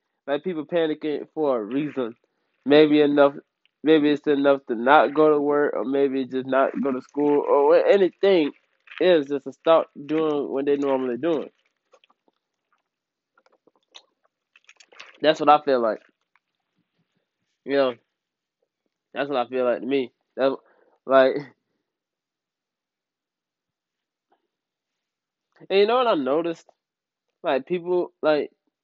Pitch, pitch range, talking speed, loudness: 145 Hz, 135-160 Hz, 125 wpm, -22 LUFS